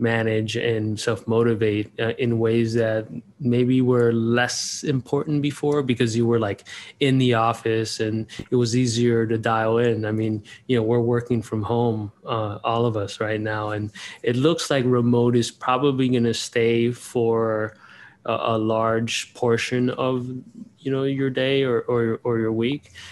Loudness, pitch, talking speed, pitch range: -22 LUFS, 115 Hz, 170 wpm, 110-125 Hz